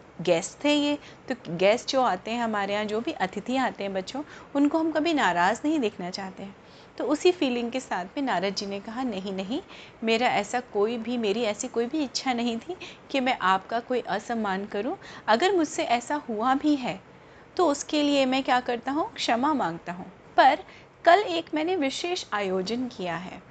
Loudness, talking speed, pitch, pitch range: -26 LUFS, 195 wpm, 245 Hz, 200-290 Hz